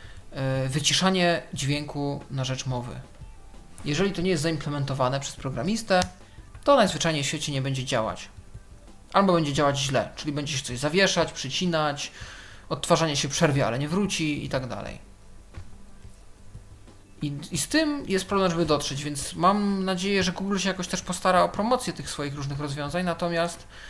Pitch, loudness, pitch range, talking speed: 145 Hz, -25 LUFS, 125-175 Hz, 155 wpm